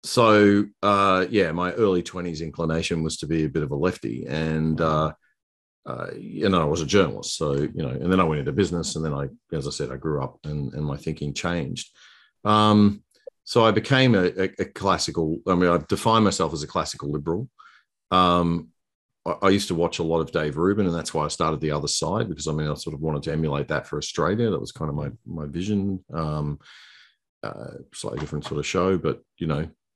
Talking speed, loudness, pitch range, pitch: 225 wpm, -24 LUFS, 75-95 Hz, 80 Hz